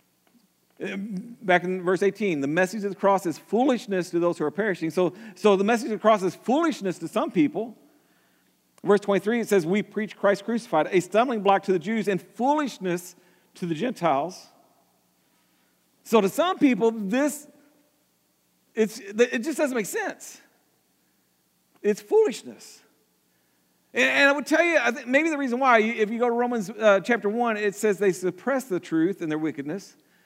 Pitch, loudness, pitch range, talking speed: 210 Hz, -24 LUFS, 185-245 Hz, 175 wpm